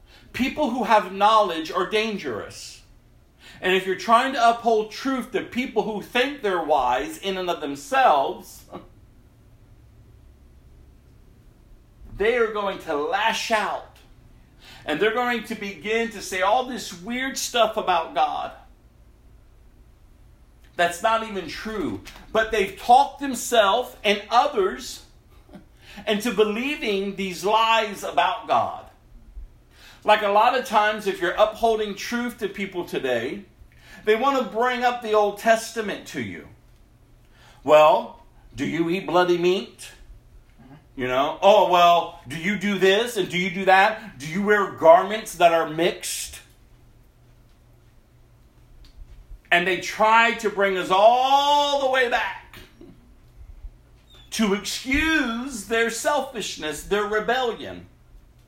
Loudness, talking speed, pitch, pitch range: -22 LUFS, 125 wpm, 205 Hz, 165-235 Hz